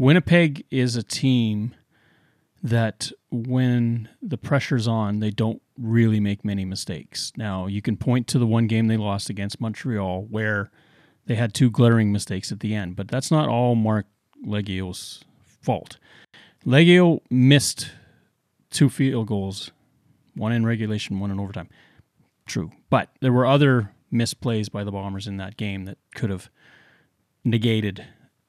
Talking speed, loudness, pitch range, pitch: 145 wpm, -23 LUFS, 105-130 Hz, 115 Hz